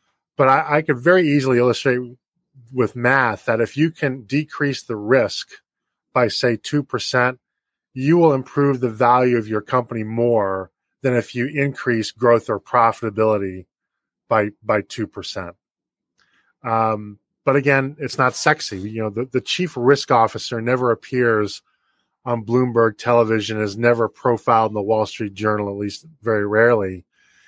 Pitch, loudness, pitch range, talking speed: 120 Hz, -19 LUFS, 110-135 Hz, 150 wpm